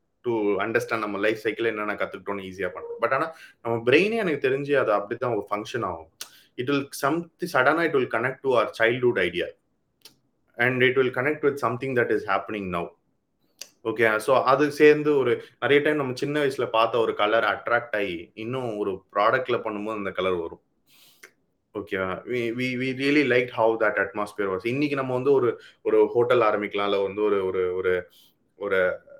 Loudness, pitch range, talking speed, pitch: -24 LUFS, 115-170 Hz, 155 wpm, 130 Hz